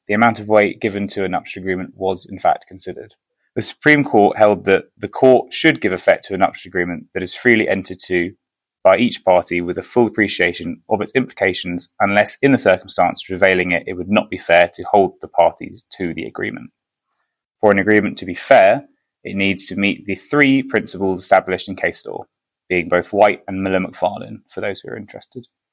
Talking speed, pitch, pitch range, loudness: 205 wpm, 95 Hz, 90-105 Hz, -17 LUFS